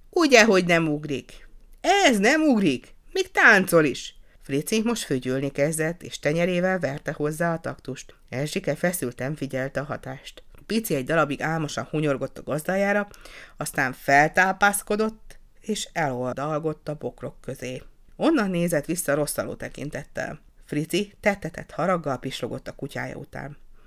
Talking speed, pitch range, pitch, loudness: 130 wpm, 140-190 Hz, 155 Hz, -24 LUFS